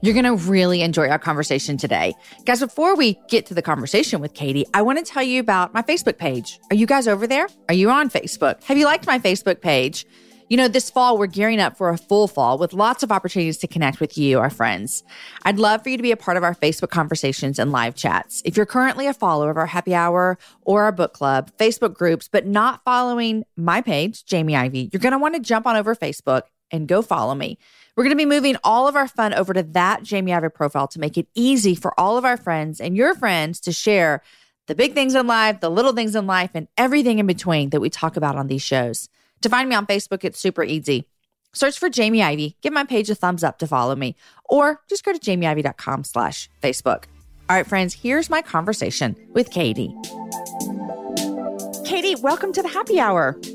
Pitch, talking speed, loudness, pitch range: 195 Hz, 225 wpm, -20 LUFS, 160-245 Hz